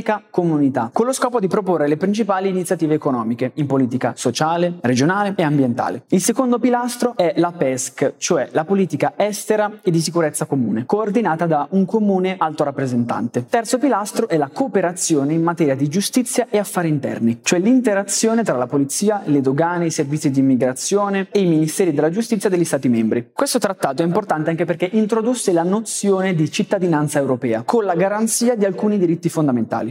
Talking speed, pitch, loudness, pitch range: 175 wpm, 175 Hz, -18 LUFS, 145-210 Hz